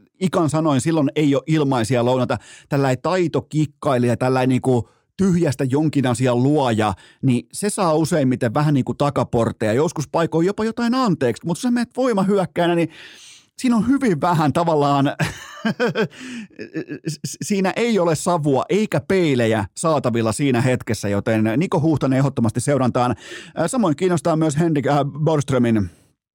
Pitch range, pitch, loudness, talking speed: 125-175 Hz, 150 Hz, -19 LUFS, 125 wpm